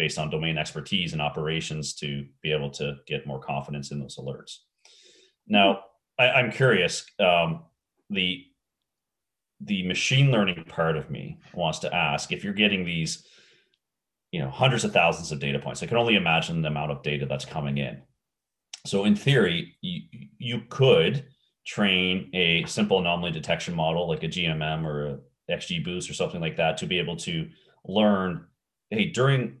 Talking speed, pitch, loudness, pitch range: 170 wpm, 85 Hz, -25 LUFS, 75-105 Hz